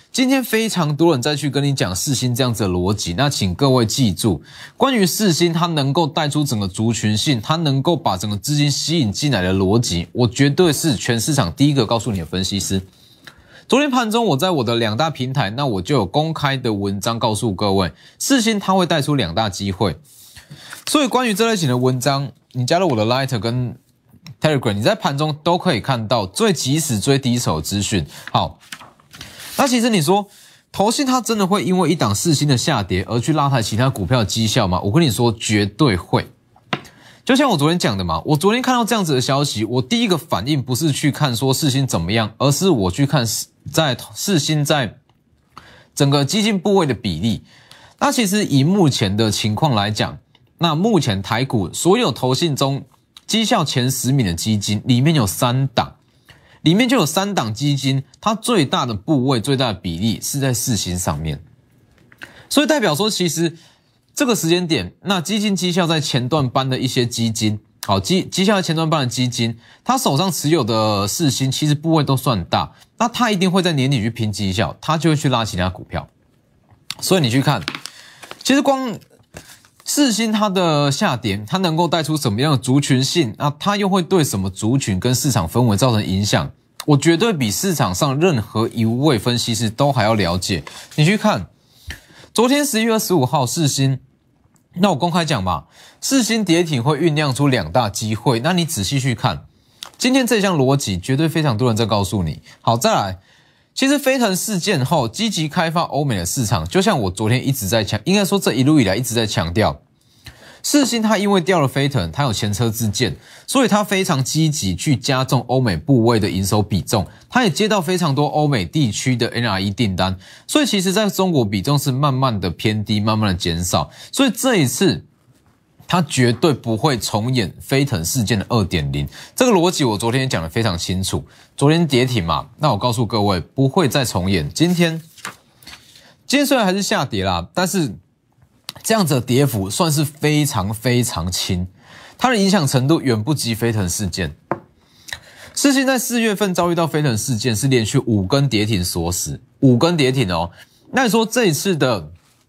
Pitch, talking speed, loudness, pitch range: 135 Hz, 285 characters per minute, -18 LUFS, 115-170 Hz